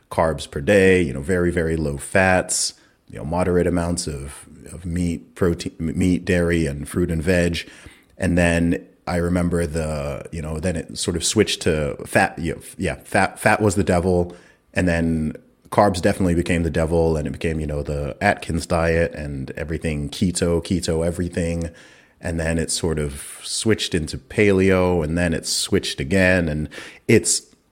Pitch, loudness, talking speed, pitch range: 85 Hz, -21 LUFS, 175 wpm, 80-90 Hz